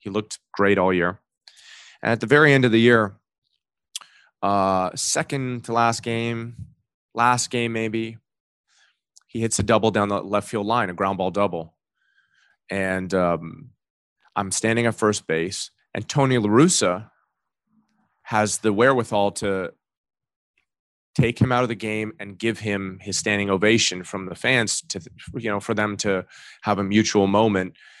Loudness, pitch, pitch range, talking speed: -22 LUFS, 105 Hz, 100-115 Hz, 155 wpm